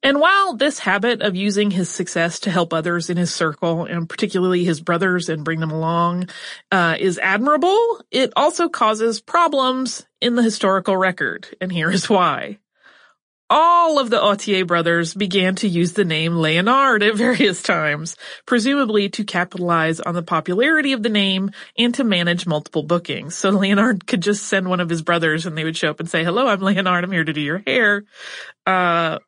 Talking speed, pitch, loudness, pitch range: 185 wpm, 190 Hz, -18 LUFS, 170-235 Hz